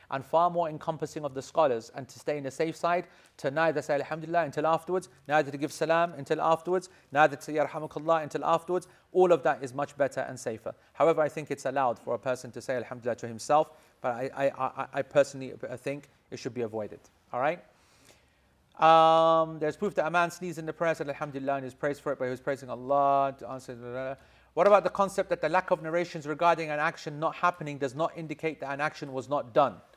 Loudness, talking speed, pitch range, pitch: -29 LUFS, 225 wpm, 140-165 Hz, 155 Hz